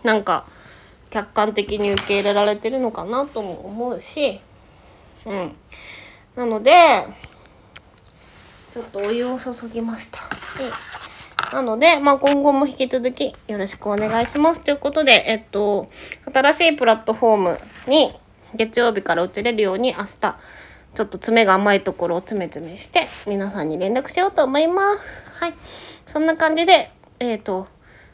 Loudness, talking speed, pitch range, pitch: -19 LUFS, 300 characters per minute, 205-280 Hz, 230 Hz